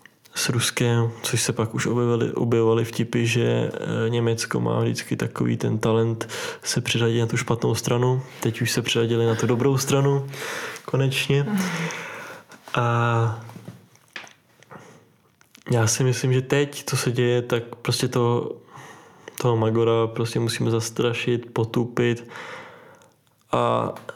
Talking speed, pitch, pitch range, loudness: 125 wpm, 120 Hz, 115-130 Hz, -23 LUFS